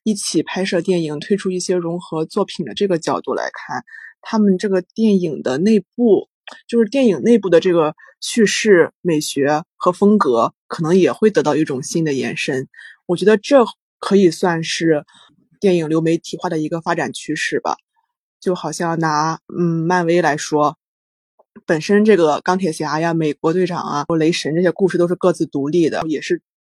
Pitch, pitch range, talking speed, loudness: 175 Hz, 160-200 Hz, 265 characters per minute, -17 LUFS